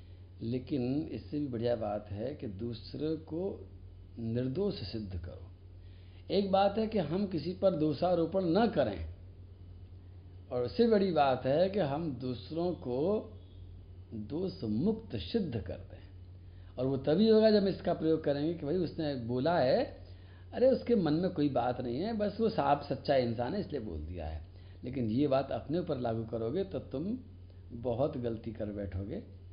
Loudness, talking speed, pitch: -33 LUFS, 165 wpm, 120 Hz